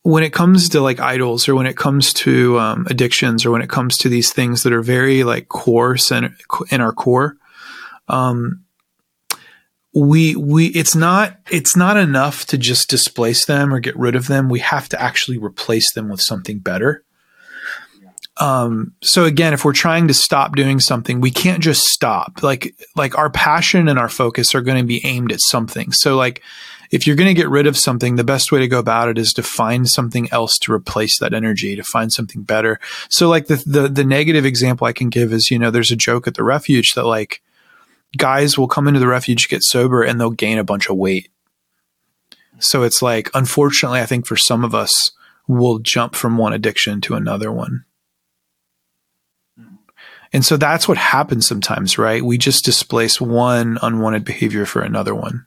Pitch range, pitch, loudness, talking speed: 115-145 Hz, 125 Hz, -15 LUFS, 200 wpm